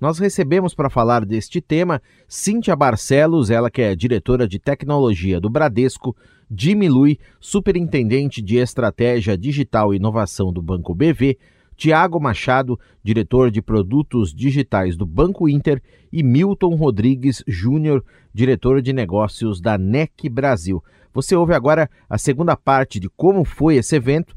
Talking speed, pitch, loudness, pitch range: 140 wpm, 130 Hz, -18 LUFS, 110-150 Hz